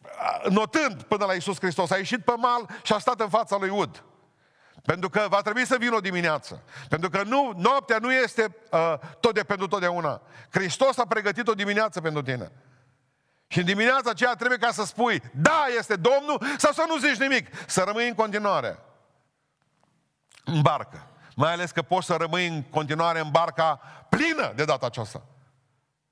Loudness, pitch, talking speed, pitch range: -25 LUFS, 195 Hz, 180 wpm, 160-235 Hz